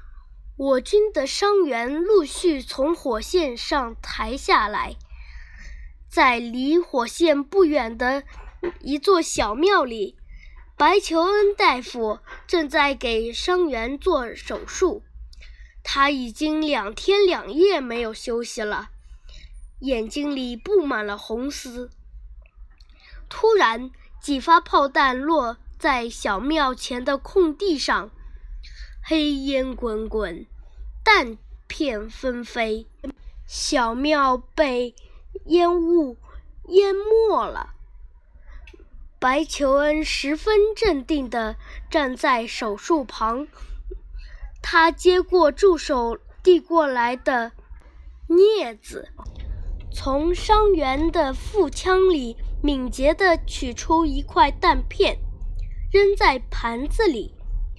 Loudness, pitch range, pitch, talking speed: -21 LUFS, 235-345 Hz, 280 Hz, 140 characters per minute